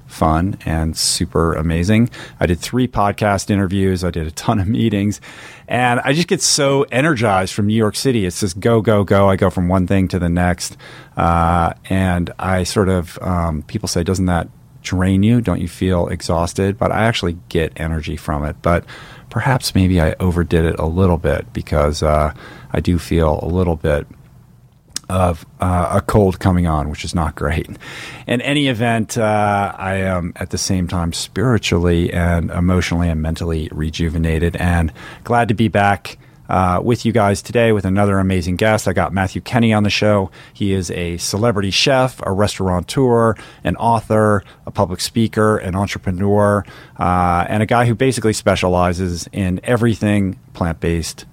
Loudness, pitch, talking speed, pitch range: -17 LUFS, 95 Hz, 175 wpm, 85-110 Hz